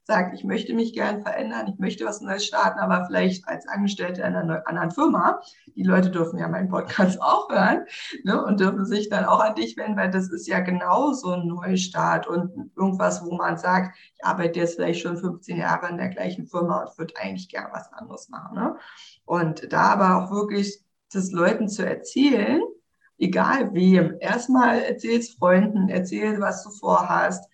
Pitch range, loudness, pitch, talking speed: 180-215 Hz, -23 LUFS, 190 Hz, 190 wpm